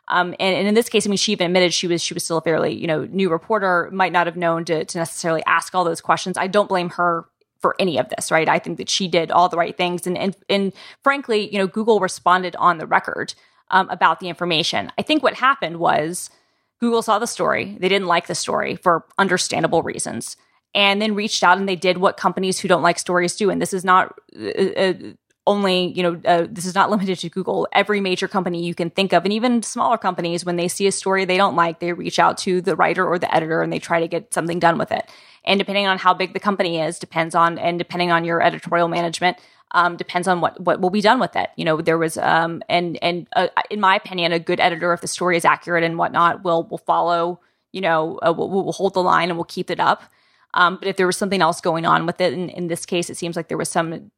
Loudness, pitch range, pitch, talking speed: -19 LUFS, 170-195 Hz, 180 Hz, 260 wpm